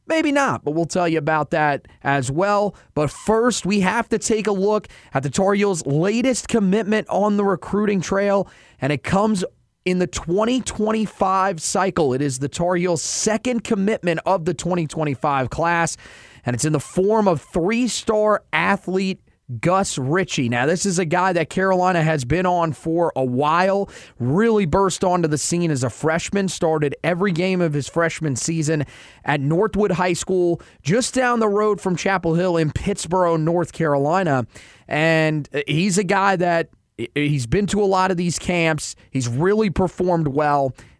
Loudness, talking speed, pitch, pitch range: -20 LUFS, 170 wpm, 175 Hz, 150-200 Hz